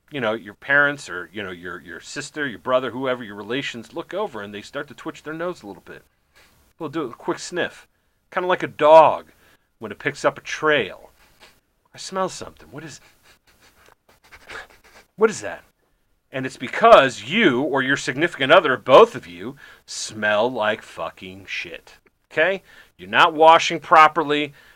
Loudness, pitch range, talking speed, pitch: -19 LUFS, 110-160 Hz, 170 wpm, 140 Hz